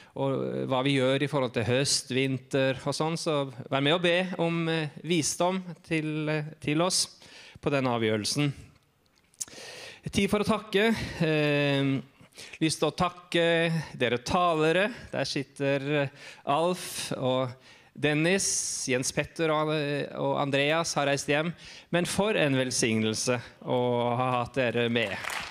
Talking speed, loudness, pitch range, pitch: 135 wpm, -27 LUFS, 130-165 Hz, 145 Hz